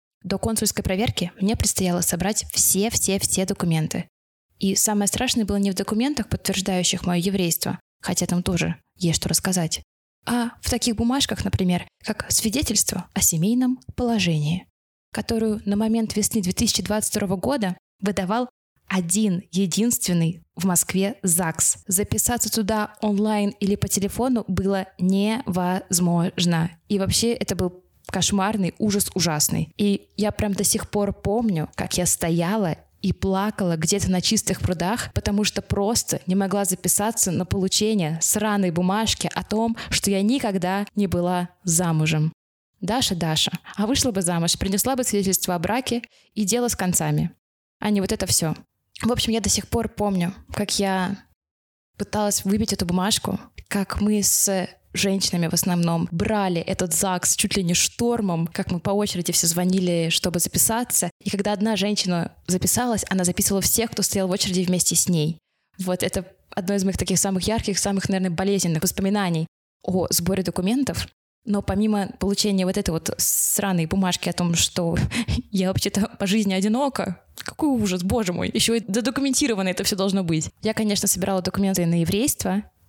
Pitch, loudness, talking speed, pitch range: 195 Hz, -22 LUFS, 155 wpm, 180-210 Hz